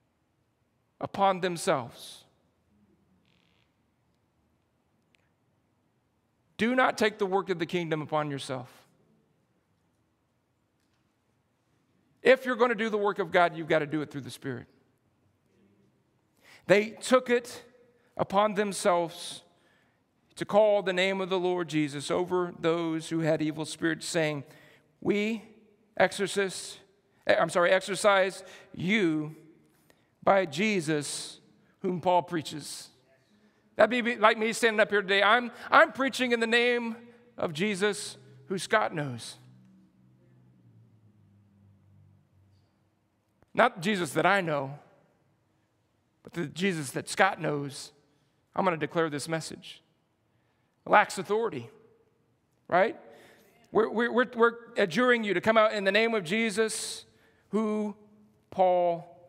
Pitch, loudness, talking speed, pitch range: 180 Hz, -27 LUFS, 115 wpm, 145-210 Hz